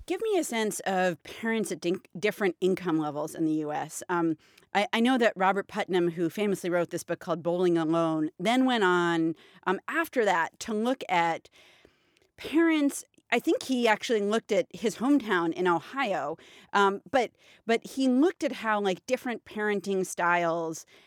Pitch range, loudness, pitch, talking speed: 175-230 Hz, -28 LUFS, 195 Hz, 170 wpm